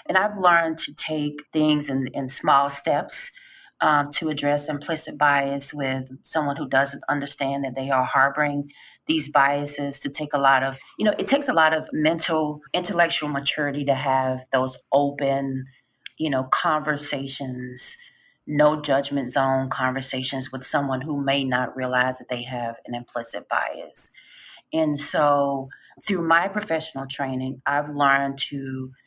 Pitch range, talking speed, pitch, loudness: 135-155 Hz, 150 wpm, 140 Hz, -22 LUFS